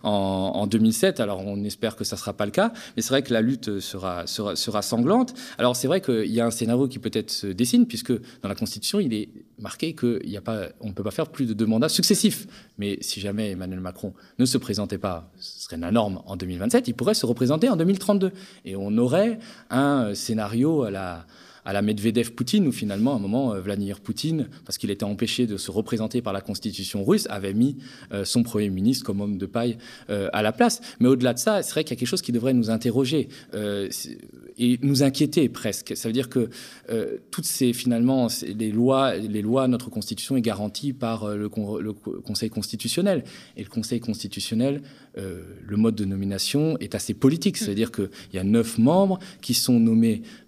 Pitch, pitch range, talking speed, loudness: 115 Hz, 105-135 Hz, 205 wpm, -24 LUFS